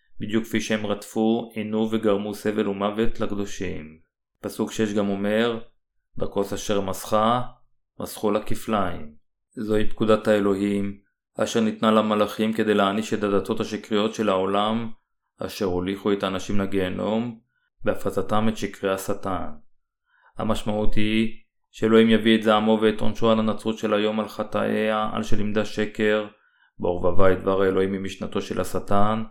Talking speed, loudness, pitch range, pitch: 135 wpm, -24 LUFS, 100-110 Hz, 105 Hz